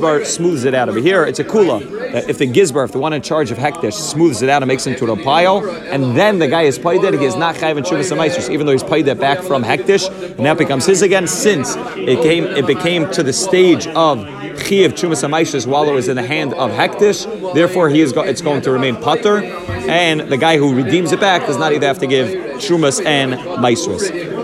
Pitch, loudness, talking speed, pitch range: 155 Hz, -14 LUFS, 250 wpm, 140-175 Hz